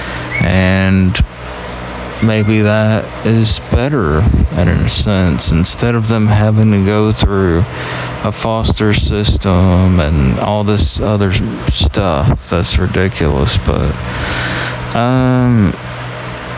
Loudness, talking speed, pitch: -13 LUFS, 100 wpm, 95 Hz